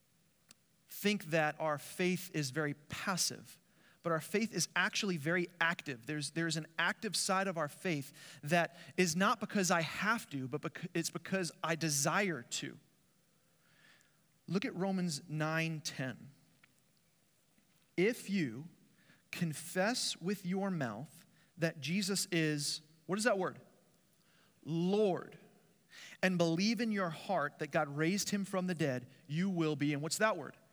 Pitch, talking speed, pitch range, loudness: 170 Hz, 145 wpm, 155-190 Hz, -36 LUFS